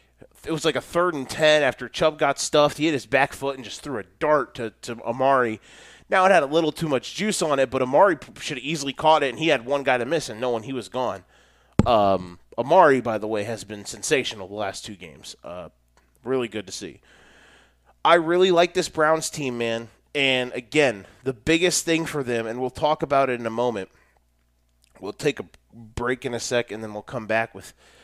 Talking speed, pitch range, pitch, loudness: 225 wpm, 110-150 Hz, 130 Hz, -23 LUFS